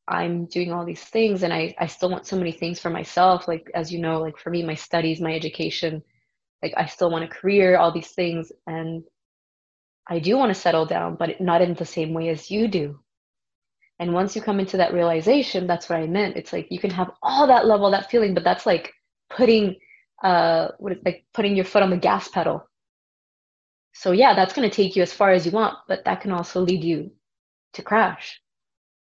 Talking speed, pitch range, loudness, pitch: 220 wpm, 165-195 Hz, -22 LUFS, 175 Hz